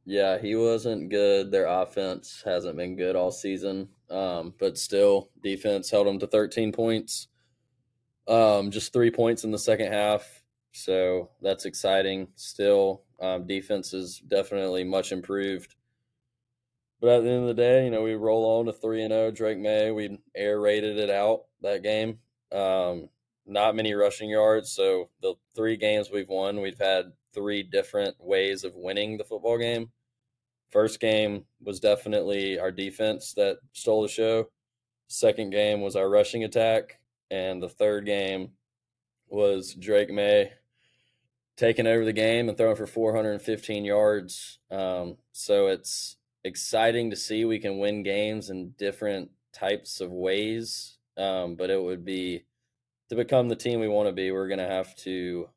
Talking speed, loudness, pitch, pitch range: 160 wpm, -26 LUFS, 105 Hz, 95-120 Hz